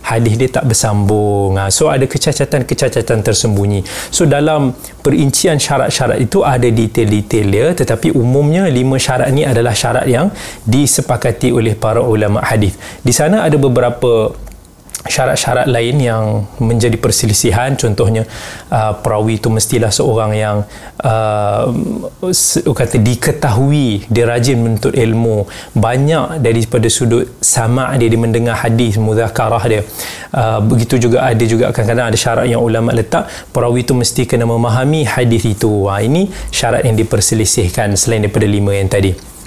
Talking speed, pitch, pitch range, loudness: 140 wpm, 115 Hz, 110-130 Hz, -13 LUFS